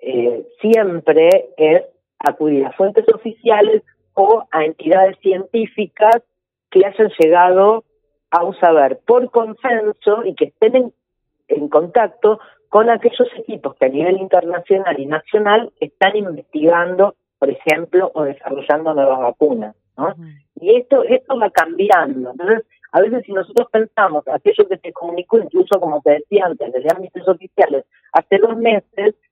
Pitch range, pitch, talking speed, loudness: 155-225 Hz, 195 Hz, 140 wpm, -15 LUFS